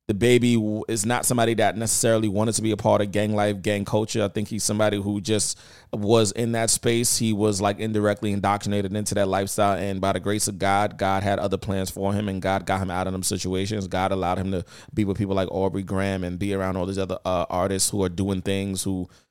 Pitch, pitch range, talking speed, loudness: 100 Hz, 95-105 Hz, 240 wpm, -23 LUFS